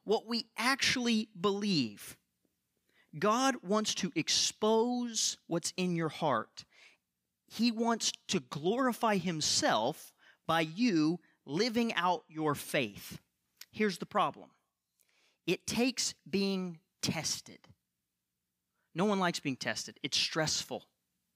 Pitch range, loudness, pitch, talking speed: 160-225 Hz, -32 LUFS, 190 Hz, 105 wpm